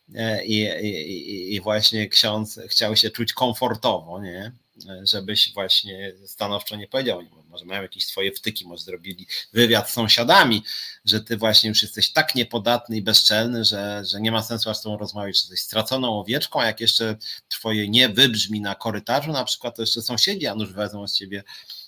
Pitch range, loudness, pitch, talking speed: 100-115 Hz, -20 LUFS, 110 Hz, 180 wpm